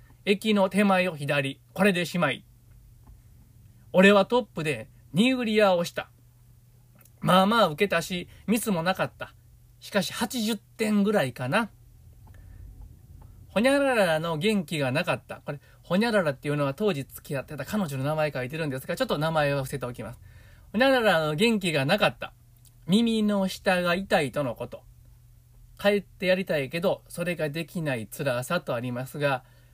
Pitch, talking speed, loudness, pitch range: 150 Hz, 320 characters per minute, -26 LUFS, 120-195 Hz